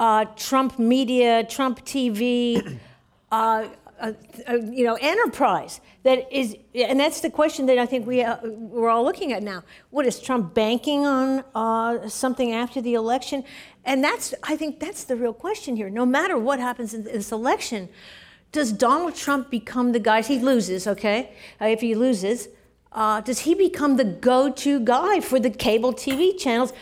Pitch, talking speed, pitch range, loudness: 250 Hz, 175 wpm, 230-270 Hz, -23 LUFS